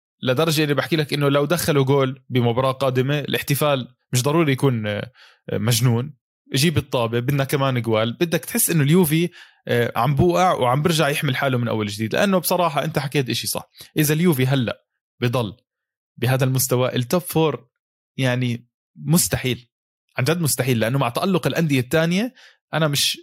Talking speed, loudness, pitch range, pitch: 150 wpm, -20 LUFS, 125-160 Hz, 140 Hz